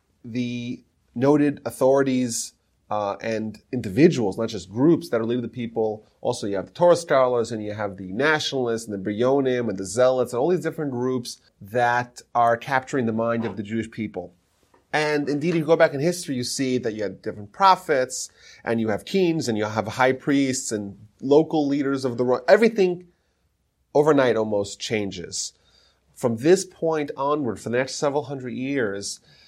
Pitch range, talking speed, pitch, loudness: 110-145 Hz, 180 wpm, 125 Hz, -23 LUFS